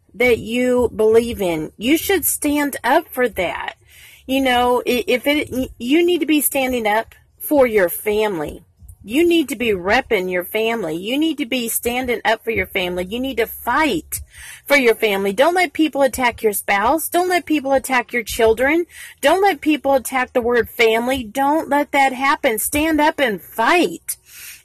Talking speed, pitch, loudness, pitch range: 180 wpm, 250 Hz, -18 LUFS, 225-290 Hz